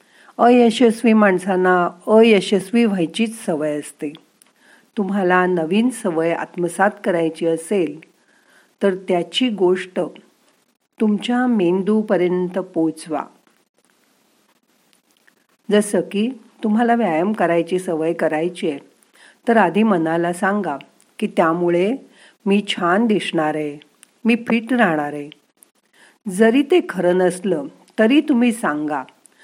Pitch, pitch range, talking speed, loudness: 190 Hz, 170-225 Hz, 95 wpm, -18 LUFS